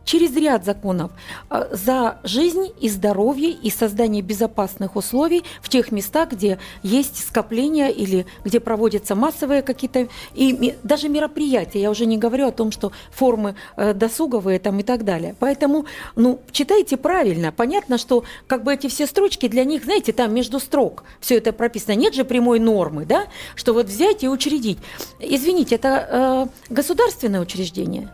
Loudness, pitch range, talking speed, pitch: -20 LUFS, 215-280 Hz, 160 wpm, 245 Hz